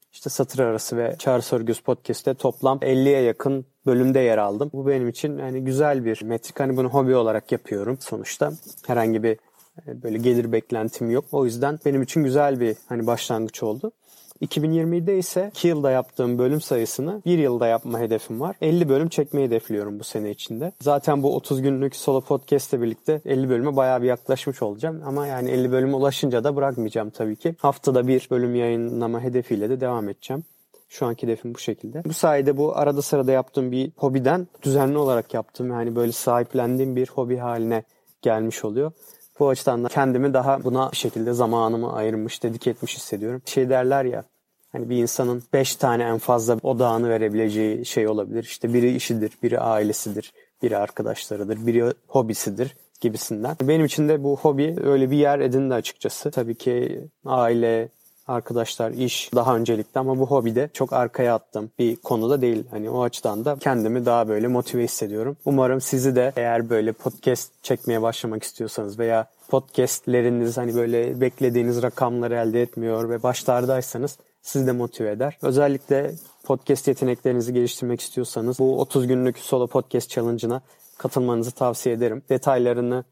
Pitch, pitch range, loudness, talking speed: 125 Hz, 115-135 Hz, -23 LUFS, 165 wpm